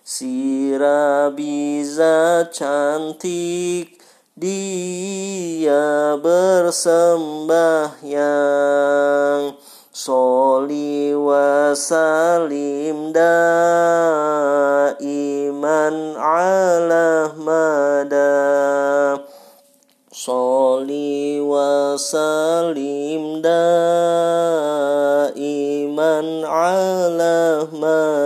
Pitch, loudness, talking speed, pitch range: 155 Hz, -17 LUFS, 35 wpm, 145-170 Hz